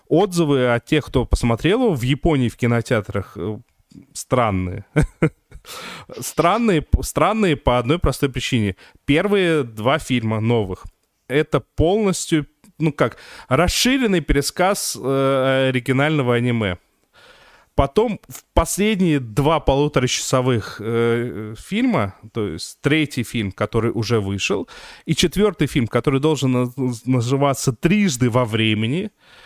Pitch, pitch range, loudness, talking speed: 135 Hz, 115-155 Hz, -19 LUFS, 100 wpm